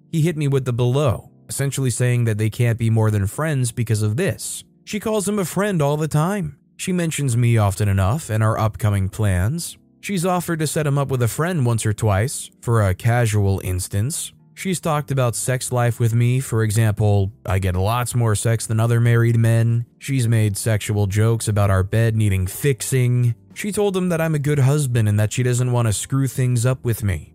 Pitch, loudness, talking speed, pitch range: 120 Hz, -20 LUFS, 215 wpm, 110-140 Hz